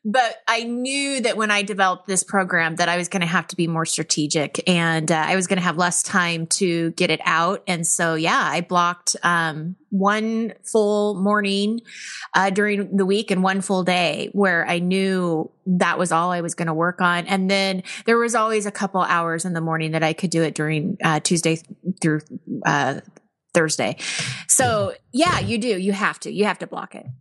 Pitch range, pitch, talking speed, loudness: 165-205 Hz, 180 Hz, 210 wpm, -20 LUFS